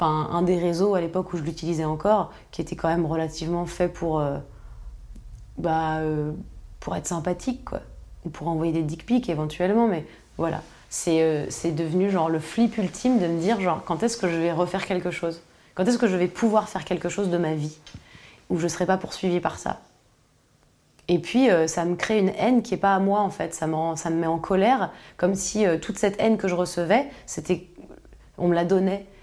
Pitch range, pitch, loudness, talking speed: 165-195 Hz, 175 Hz, -25 LUFS, 225 wpm